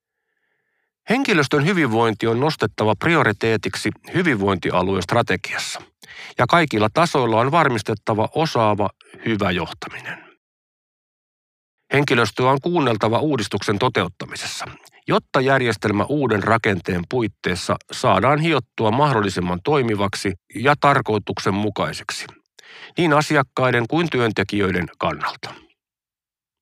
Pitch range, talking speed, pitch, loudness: 105-150 Hz, 80 wpm, 115 Hz, -20 LUFS